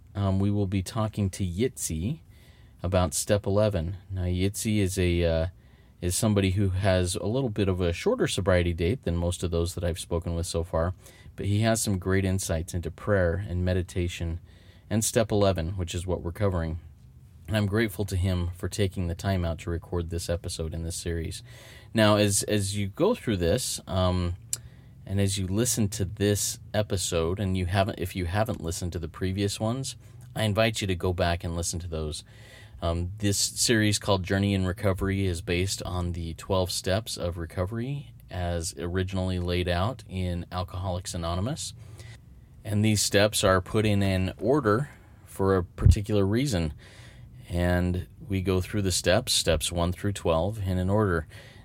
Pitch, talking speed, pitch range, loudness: 95 Hz, 180 wpm, 90-105 Hz, -27 LUFS